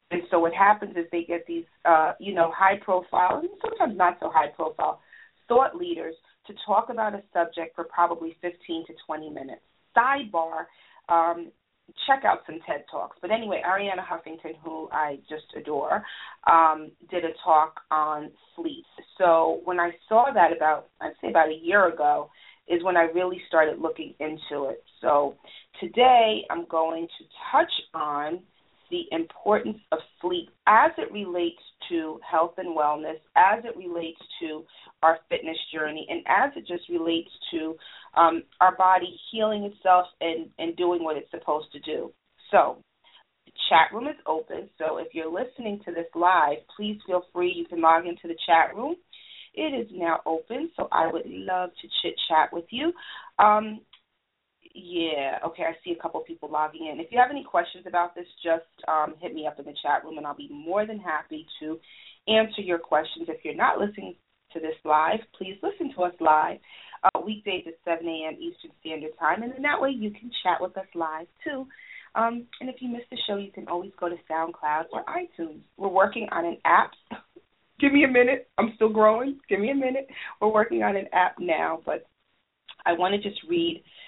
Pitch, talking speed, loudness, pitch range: 175 Hz, 190 wpm, -25 LUFS, 160-215 Hz